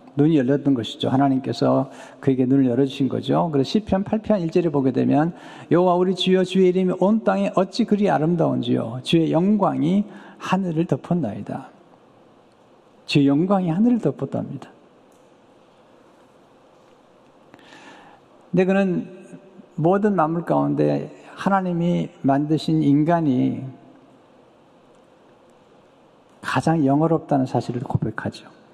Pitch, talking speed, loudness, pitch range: 160 Hz, 250 characters per minute, -21 LUFS, 135-185 Hz